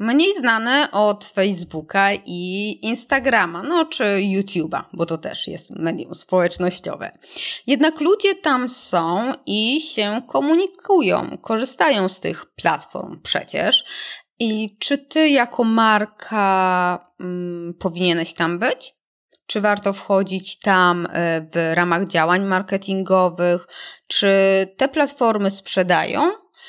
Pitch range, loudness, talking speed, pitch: 180-255 Hz, -19 LUFS, 110 wpm, 200 Hz